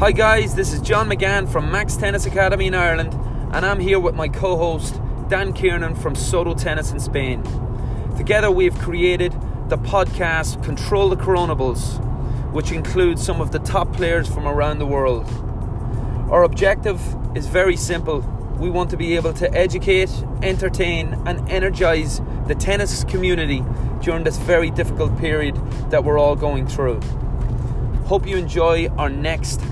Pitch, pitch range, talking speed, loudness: 130 Hz, 120-165 Hz, 160 wpm, -20 LUFS